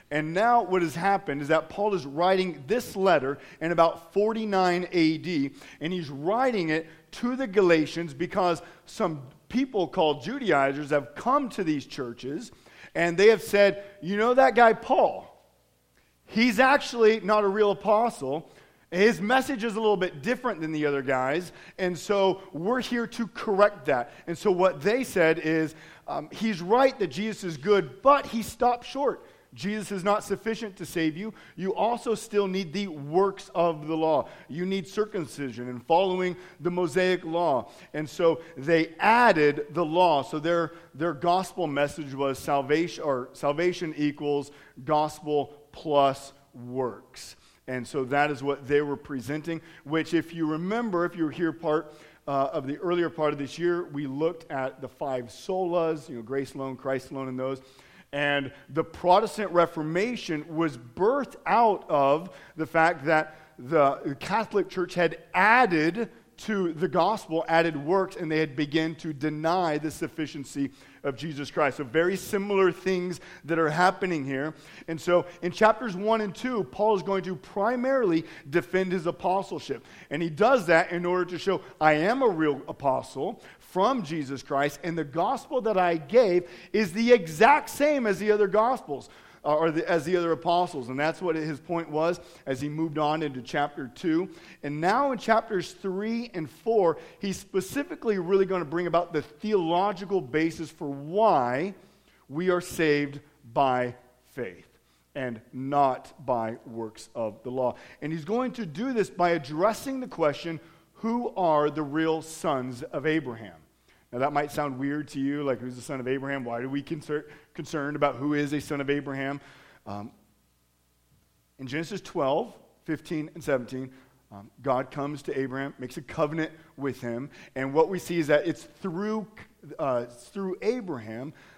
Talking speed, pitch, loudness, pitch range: 170 wpm, 165 Hz, -27 LUFS, 145-195 Hz